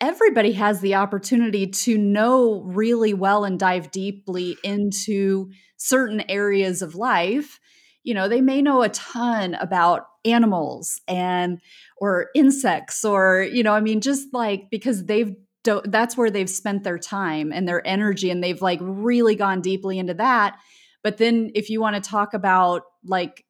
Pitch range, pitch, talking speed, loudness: 190-230 Hz, 205 Hz, 160 wpm, -21 LUFS